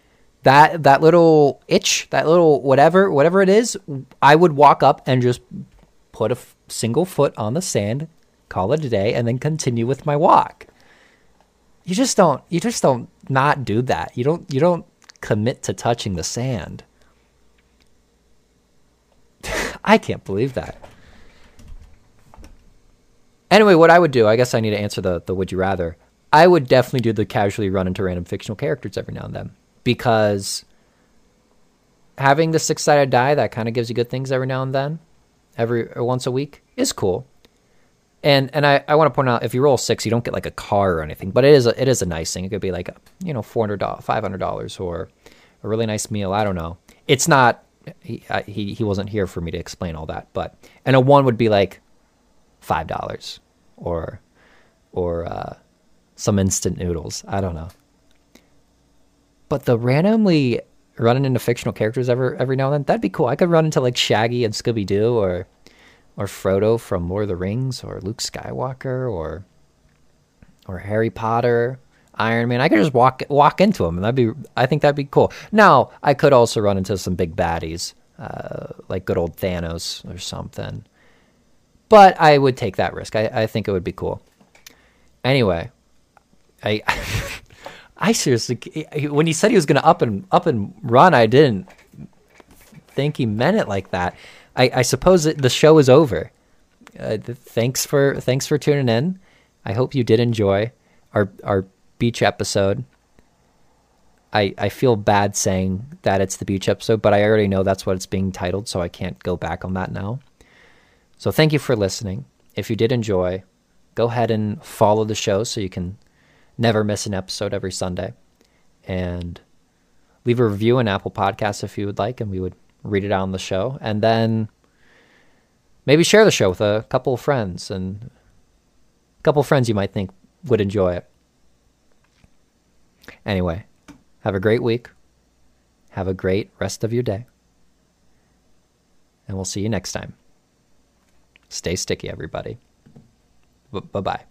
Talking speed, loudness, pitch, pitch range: 185 wpm, -19 LUFS, 115 Hz, 95-135 Hz